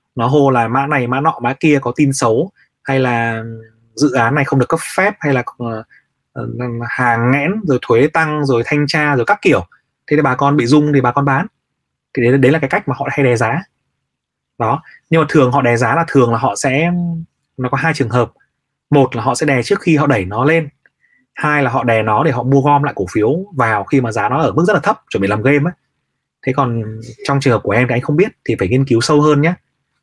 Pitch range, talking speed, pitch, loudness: 120-150 Hz, 255 wpm, 135 Hz, -14 LUFS